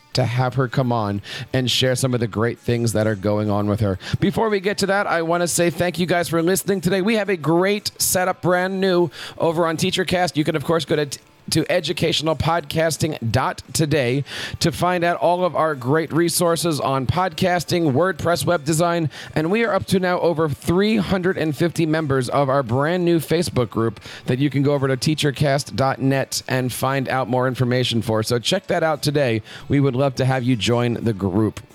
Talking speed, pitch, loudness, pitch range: 200 wpm, 155 Hz, -20 LUFS, 125-175 Hz